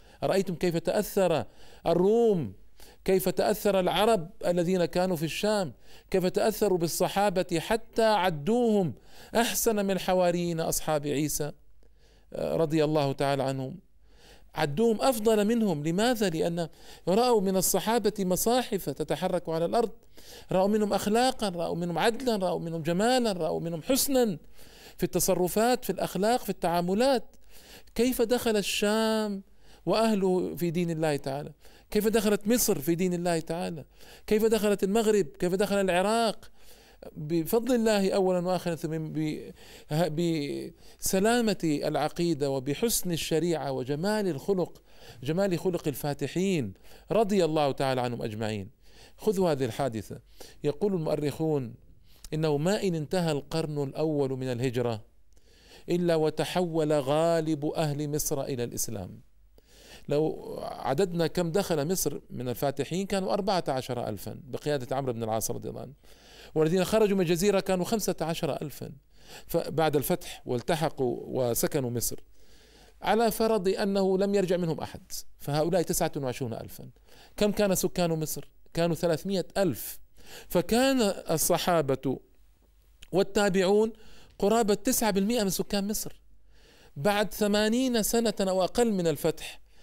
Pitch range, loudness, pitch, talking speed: 150-205 Hz, -28 LUFS, 175 Hz, 120 wpm